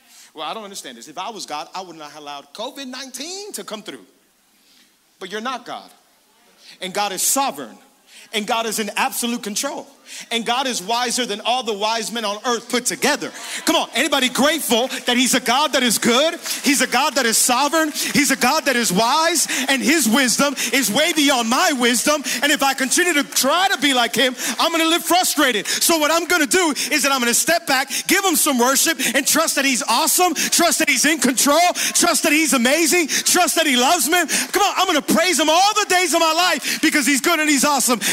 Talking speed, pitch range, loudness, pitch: 225 wpm, 240-320 Hz, -17 LUFS, 275 Hz